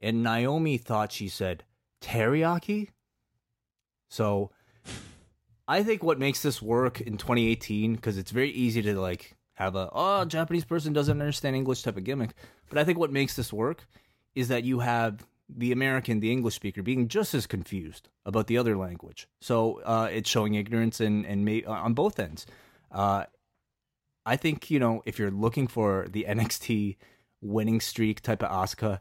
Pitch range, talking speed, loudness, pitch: 105-130 Hz, 175 wpm, -28 LUFS, 115 Hz